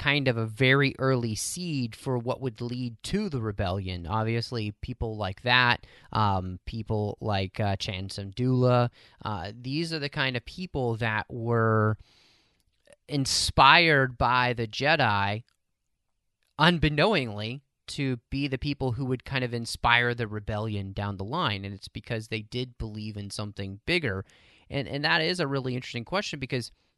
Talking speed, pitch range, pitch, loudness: 155 wpm, 105-135 Hz, 120 Hz, -27 LUFS